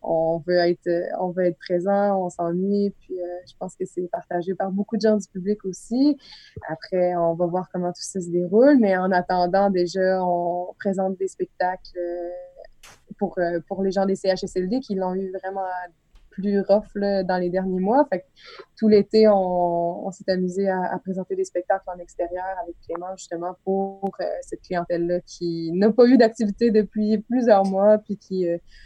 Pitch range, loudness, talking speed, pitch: 175-200 Hz, -23 LUFS, 195 wpm, 190 Hz